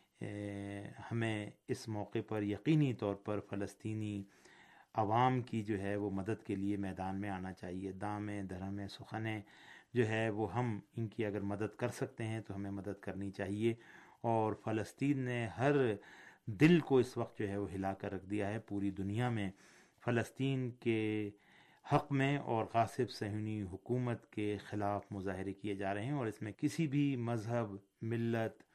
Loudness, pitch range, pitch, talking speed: -38 LUFS, 100-120 Hz, 110 Hz, 165 wpm